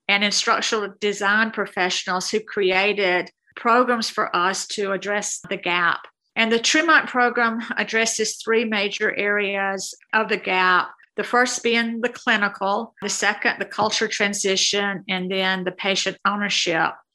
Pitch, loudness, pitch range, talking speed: 205 Hz, -21 LUFS, 195-225 Hz, 135 wpm